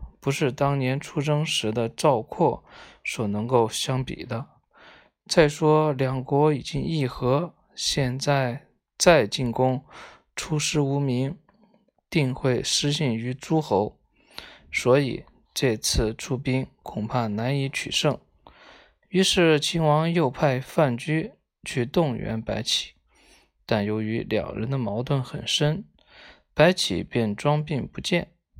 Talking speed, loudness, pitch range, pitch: 170 characters per minute, -24 LUFS, 125-155 Hz, 140 Hz